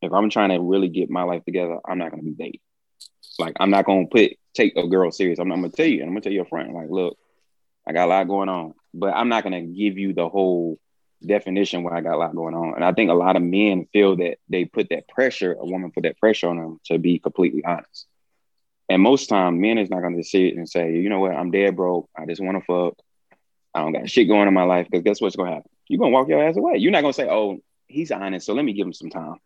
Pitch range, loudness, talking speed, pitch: 85-100 Hz, -21 LUFS, 295 wpm, 90 Hz